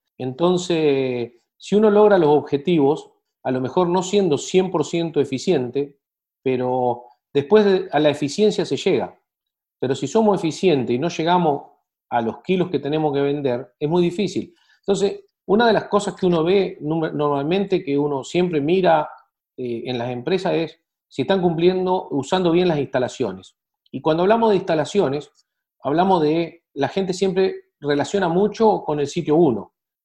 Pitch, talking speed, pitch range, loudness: 170 Hz, 160 wpm, 140-190 Hz, -20 LUFS